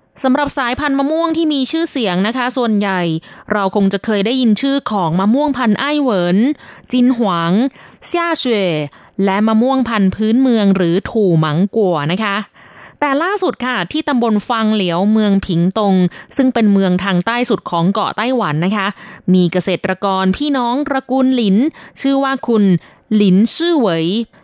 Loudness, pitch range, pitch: -15 LUFS, 190-260 Hz, 215 Hz